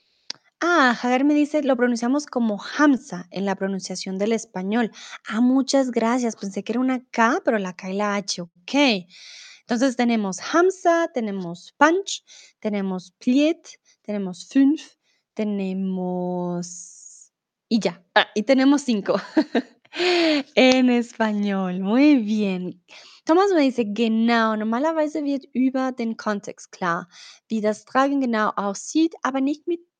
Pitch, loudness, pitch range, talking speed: 235 Hz, -22 LUFS, 200-280 Hz, 130 wpm